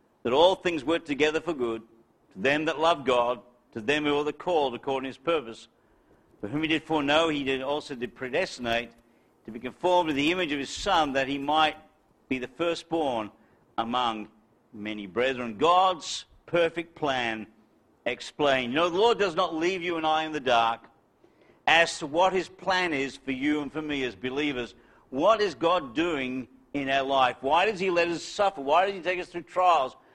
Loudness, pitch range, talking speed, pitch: -27 LUFS, 125-170 Hz, 200 wpm, 145 Hz